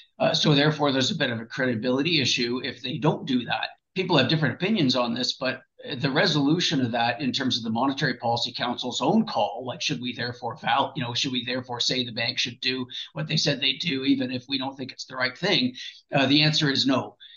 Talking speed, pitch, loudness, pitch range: 240 wpm, 130 Hz, -24 LUFS, 125-150 Hz